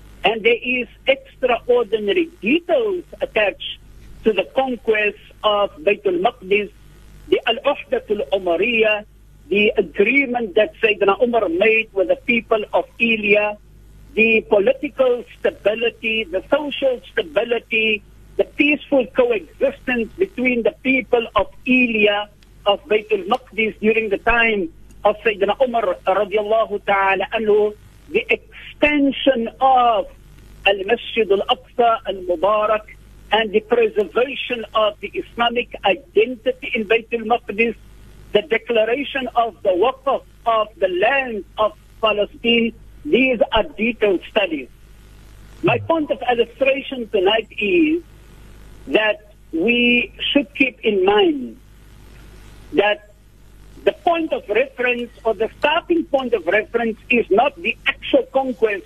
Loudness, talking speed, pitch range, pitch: -19 LUFS, 110 wpm, 210-270 Hz, 230 Hz